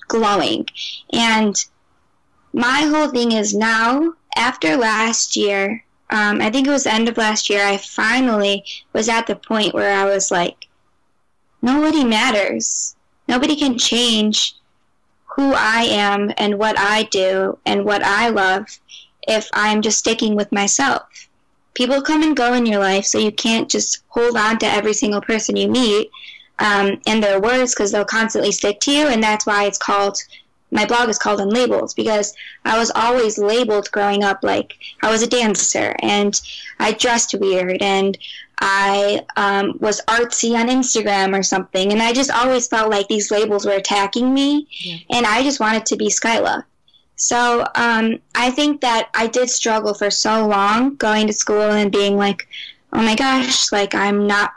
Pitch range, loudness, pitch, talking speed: 205-240 Hz, -17 LUFS, 220 Hz, 175 wpm